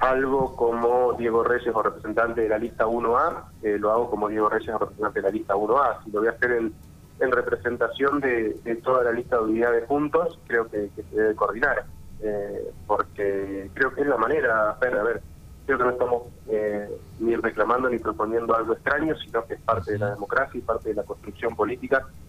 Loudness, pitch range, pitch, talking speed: -25 LUFS, 105-125 Hz, 115 Hz, 210 wpm